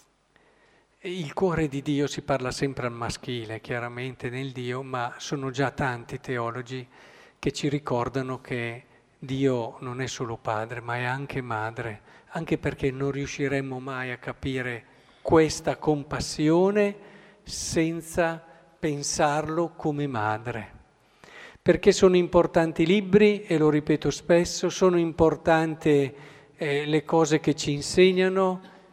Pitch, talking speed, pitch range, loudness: 145 Hz, 125 wpm, 130-165 Hz, -26 LUFS